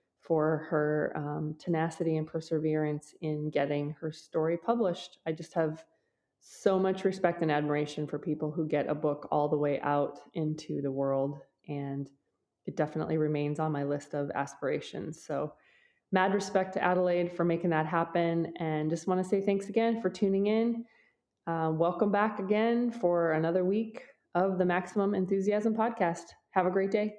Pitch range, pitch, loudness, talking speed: 150-190 Hz, 165 Hz, -31 LUFS, 165 wpm